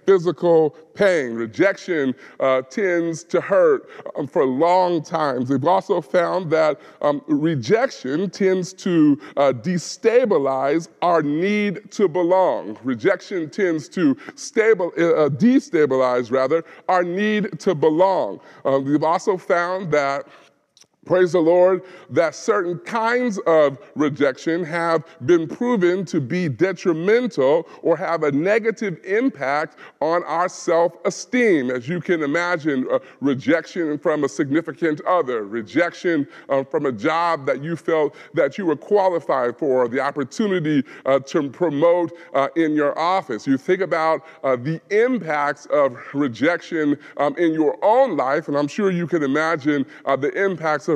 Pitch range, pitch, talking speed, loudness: 150-190 Hz, 170 Hz, 140 wpm, -20 LUFS